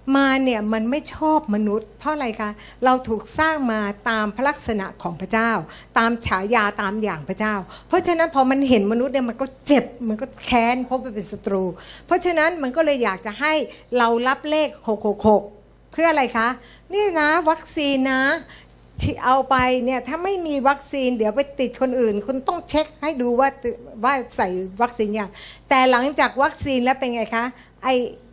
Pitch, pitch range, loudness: 255 Hz, 220-280 Hz, -21 LUFS